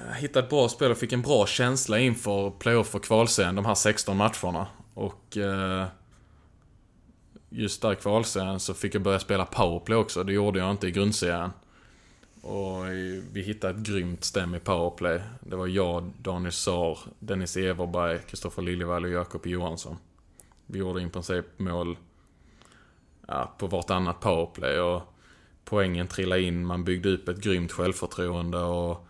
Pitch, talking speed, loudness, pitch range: 95 Hz, 155 wpm, -28 LUFS, 90-100 Hz